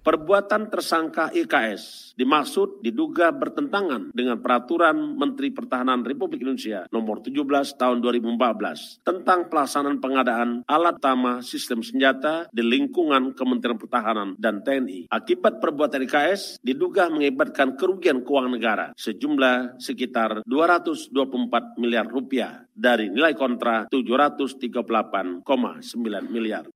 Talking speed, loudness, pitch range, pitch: 105 wpm, -23 LUFS, 125-180 Hz, 135 Hz